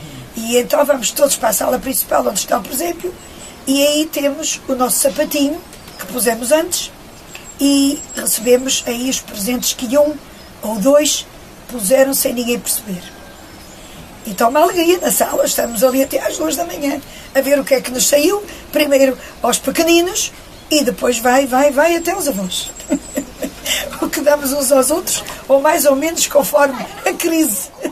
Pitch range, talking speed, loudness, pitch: 255-305 Hz, 170 wpm, -15 LUFS, 280 Hz